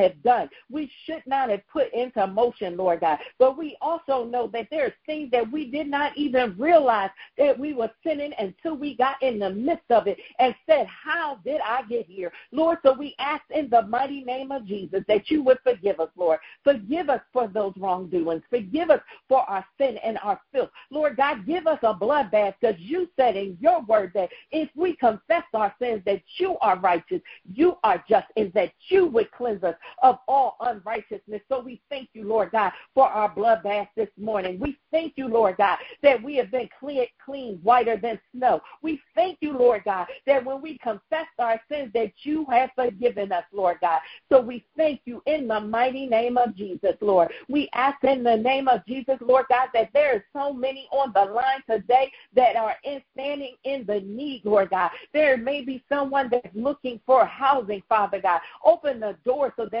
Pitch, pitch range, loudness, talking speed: 255 Hz, 220-285 Hz, -24 LUFS, 205 wpm